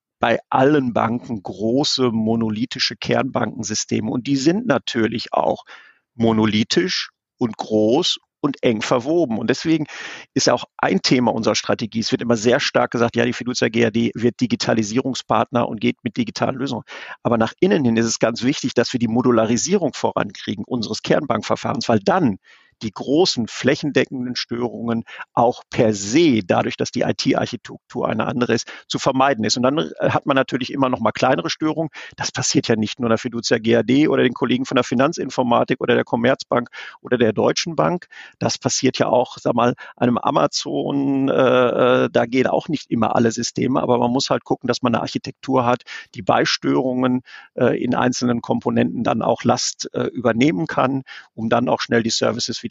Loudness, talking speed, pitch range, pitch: -19 LUFS, 175 wpm, 115-130 Hz, 120 Hz